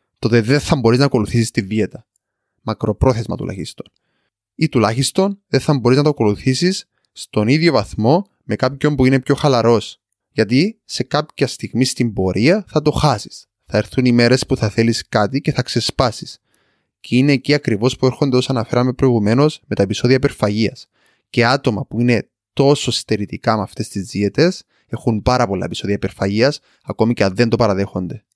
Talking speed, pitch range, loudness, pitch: 170 wpm, 110-135 Hz, -17 LUFS, 120 Hz